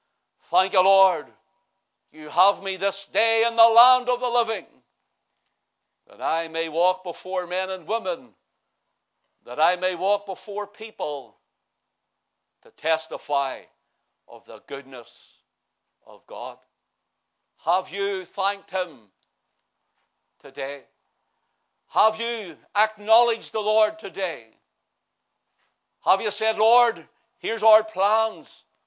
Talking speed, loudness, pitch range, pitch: 110 wpm, -23 LUFS, 180-220 Hz, 200 Hz